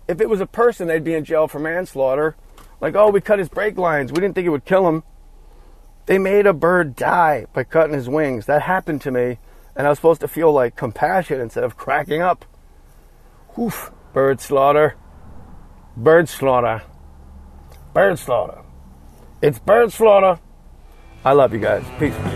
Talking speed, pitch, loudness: 175 wpm, 145 Hz, -18 LUFS